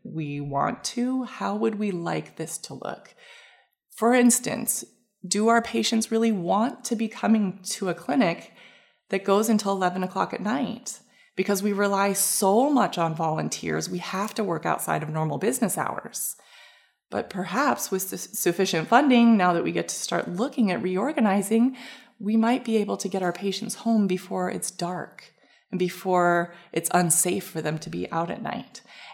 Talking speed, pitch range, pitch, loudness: 170 wpm, 180-230 Hz, 200 Hz, -25 LUFS